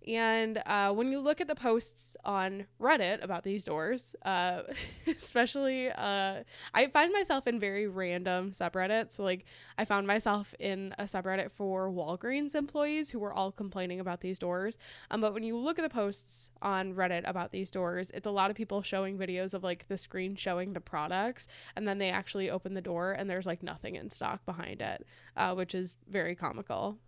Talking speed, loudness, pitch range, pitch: 195 wpm, -34 LUFS, 185-220 Hz, 195 Hz